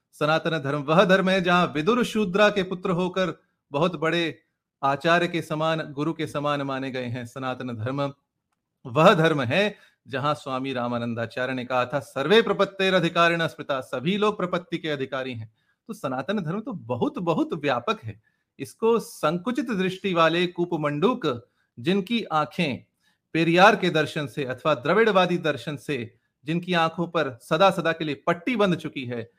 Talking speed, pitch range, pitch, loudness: 155 wpm, 140-185 Hz, 160 Hz, -24 LUFS